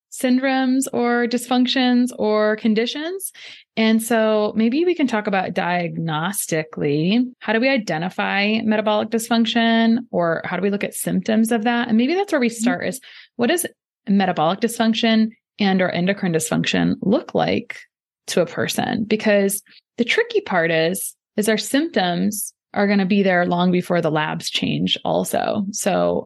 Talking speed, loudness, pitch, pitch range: 155 wpm, -20 LUFS, 215 Hz, 185-240 Hz